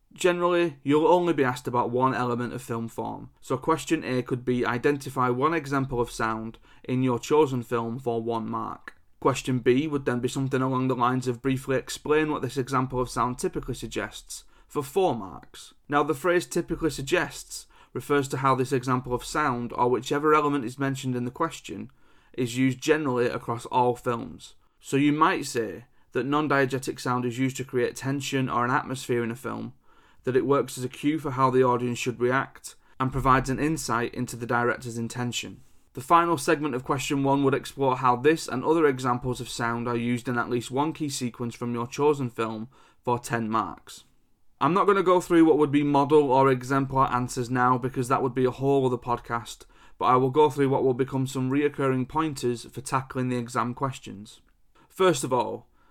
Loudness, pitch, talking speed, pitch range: -26 LUFS, 130 Hz, 200 wpm, 120-145 Hz